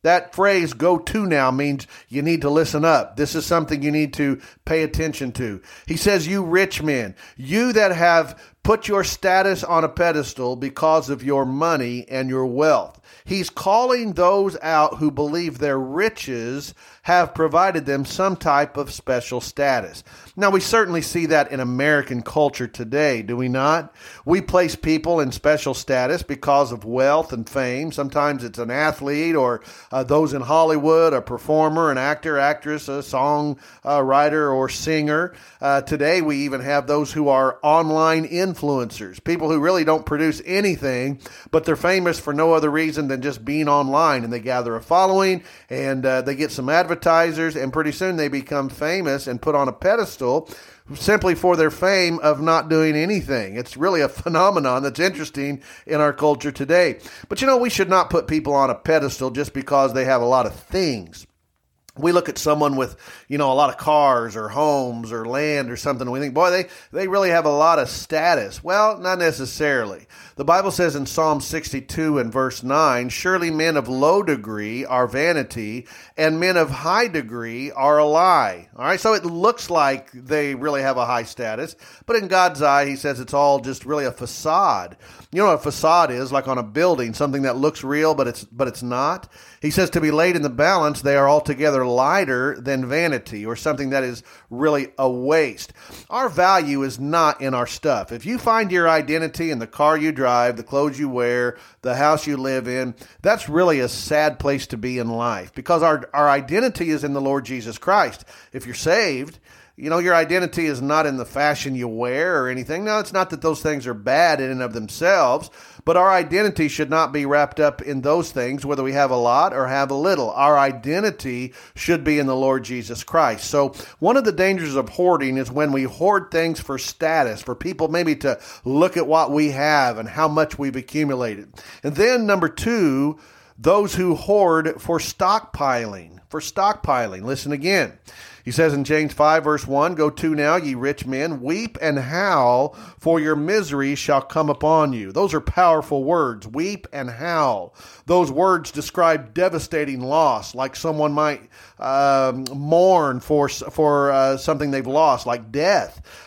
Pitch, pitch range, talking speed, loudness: 150 Hz, 135-165 Hz, 190 wpm, -20 LUFS